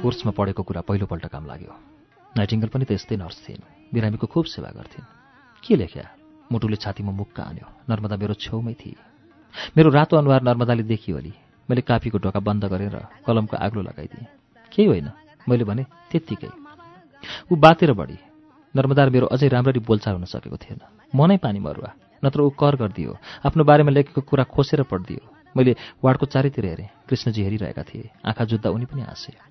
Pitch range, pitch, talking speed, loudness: 105-140 Hz, 120 Hz, 165 wpm, -21 LUFS